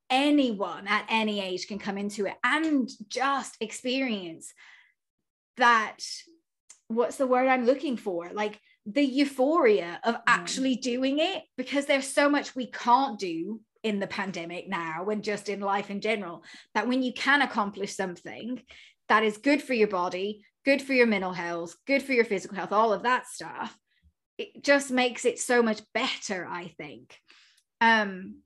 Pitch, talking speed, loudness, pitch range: 230 Hz, 165 wpm, -27 LUFS, 200-265 Hz